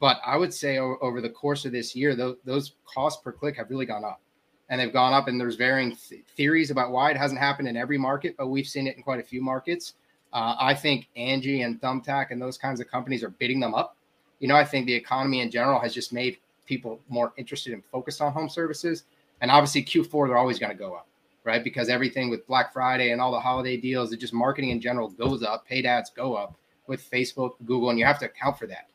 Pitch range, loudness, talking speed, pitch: 120-140 Hz, -26 LUFS, 245 wpm, 130 Hz